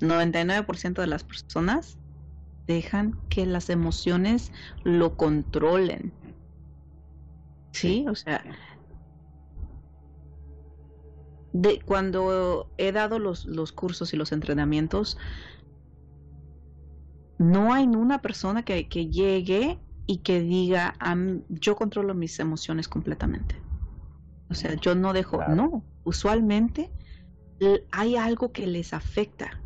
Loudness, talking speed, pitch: -26 LUFS, 105 wpm, 165 Hz